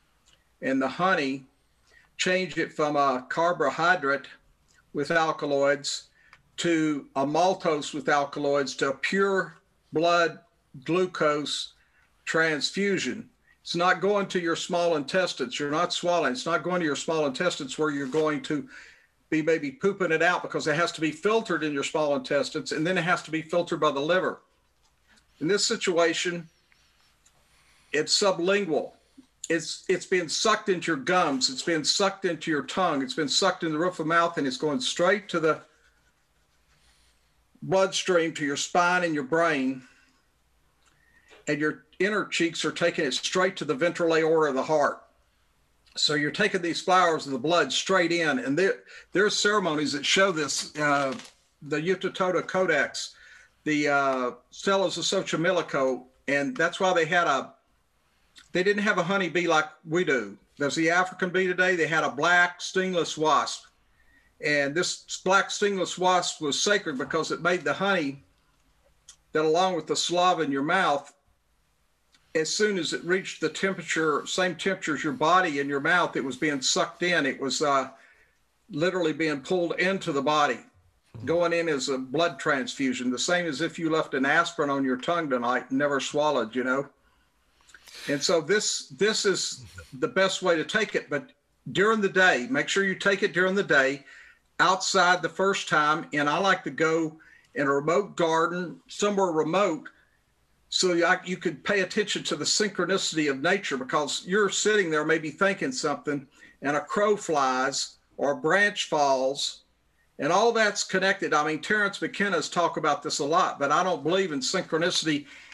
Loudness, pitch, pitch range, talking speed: -25 LUFS, 165 Hz, 145-185 Hz, 170 wpm